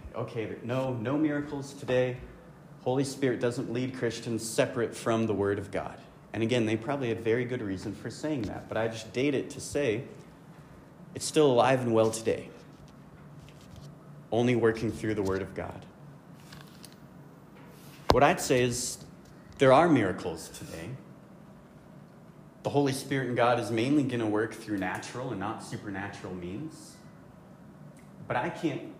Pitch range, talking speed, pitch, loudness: 110-135 Hz, 155 wpm, 120 Hz, -29 LUFS